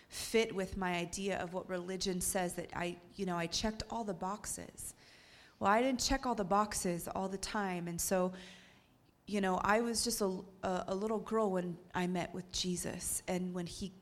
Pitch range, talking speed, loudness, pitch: 180-205 Hz, 200 wpm, -36 LUFS, 190 Hz